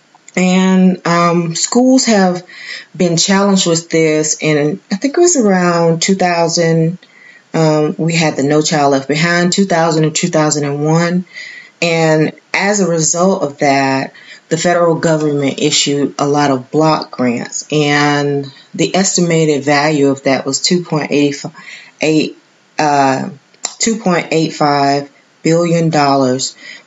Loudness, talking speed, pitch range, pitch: -13 LUFS, 120 wpm, 145-175 Hz, 160 Hz